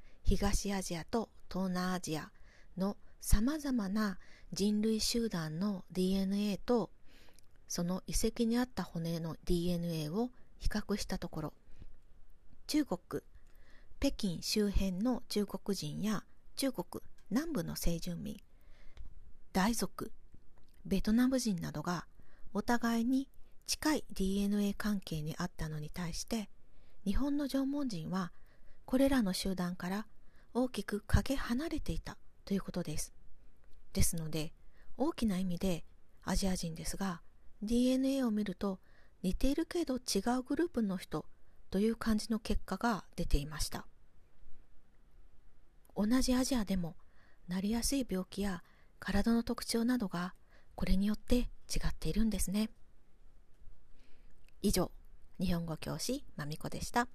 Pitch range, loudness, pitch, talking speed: 175-230 Hz, -36 LUFS, 195 Hz, 245 characters per minute